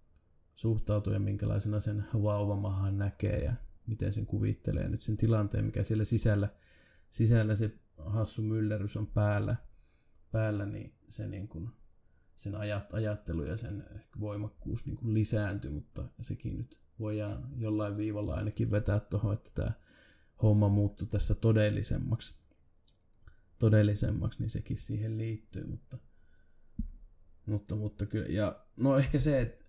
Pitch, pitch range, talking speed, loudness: 105 Hz, 100-110 Hz, 130 wpm, -33 LUFS